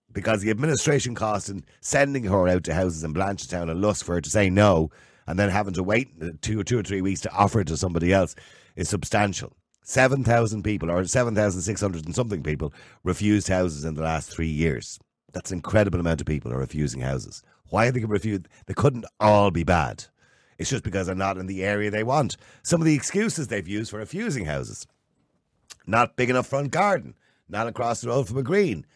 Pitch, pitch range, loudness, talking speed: 105 Hz, 90-120 Hz, -24 LUFS, 220 wpm